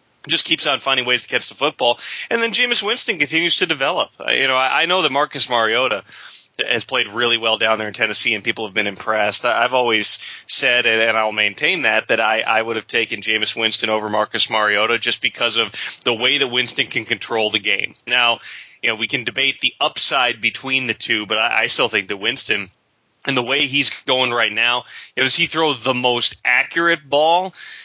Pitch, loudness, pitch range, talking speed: 125 Hz, -17 LUFS, 110-145 Hz, 205 wpm